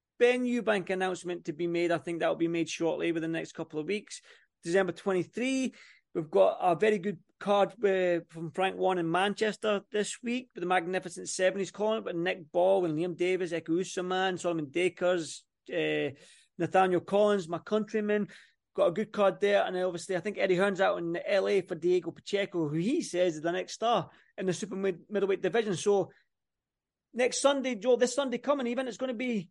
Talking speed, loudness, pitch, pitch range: 200 wpm, -30 LUFS, 190 Hz, 175-210 Hz